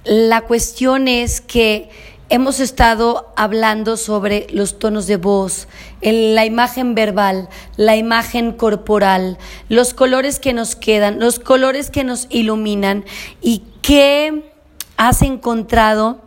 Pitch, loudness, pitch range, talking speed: 225 Hz, -15 LUFS, 210-245 Hz, 120 wpm